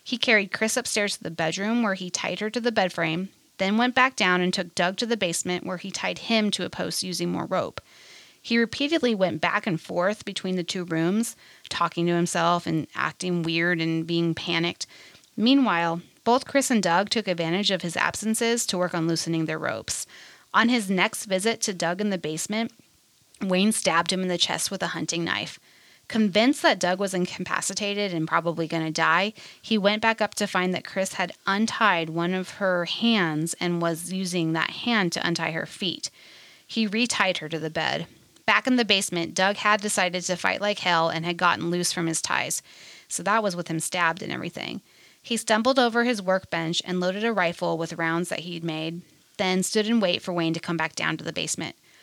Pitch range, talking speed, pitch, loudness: 170-215 Hz, 210 wpm, 185 Hz, -25 LUFS